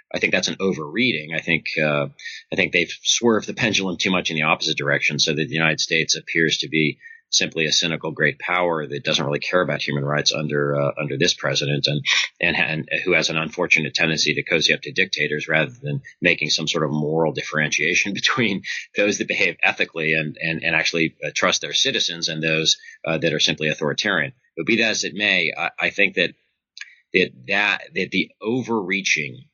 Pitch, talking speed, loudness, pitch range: 80 Hz, 205 wpm, -20 LUFS, 75-85 Hz